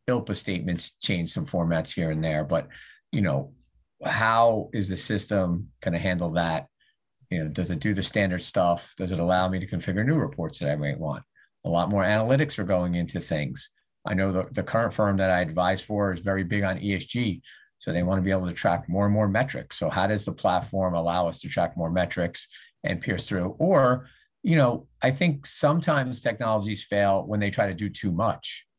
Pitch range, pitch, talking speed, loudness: 85-110 Hz, 95 Hz, 215 wpm, -26 LUFS